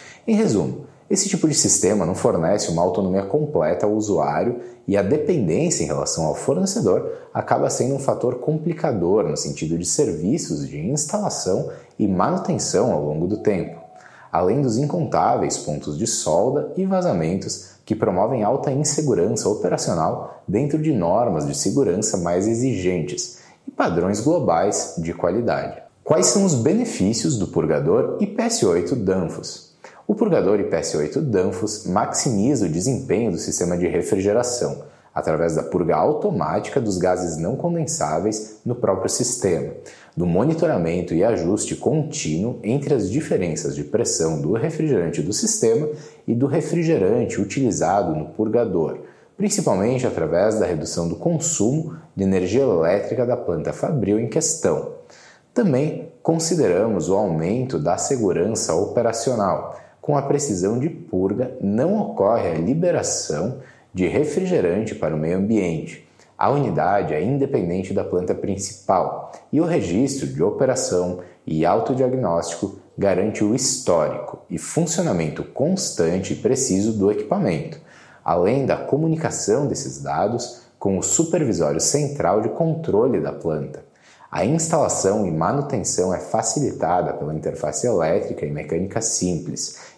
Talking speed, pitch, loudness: 130 wpm, 115 Hz, -21 LUFS